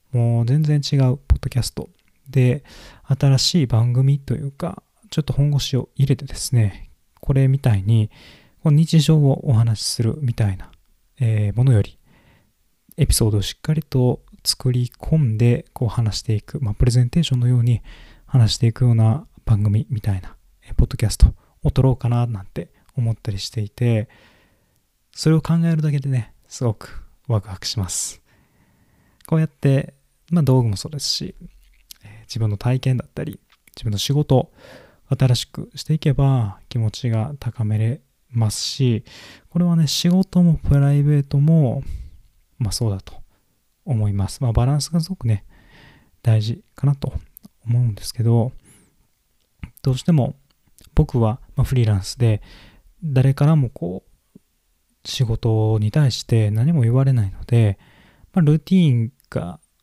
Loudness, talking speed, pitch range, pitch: -20 LUFS, 290 characters per minute, 110-140 Hz, 125 Hz